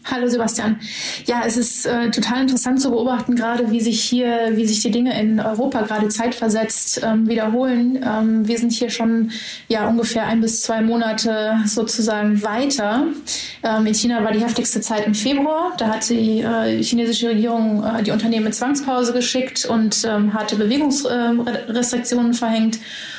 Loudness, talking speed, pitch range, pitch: -18 LUFS, 170 wpm, 220-245 Hz, 230 Hz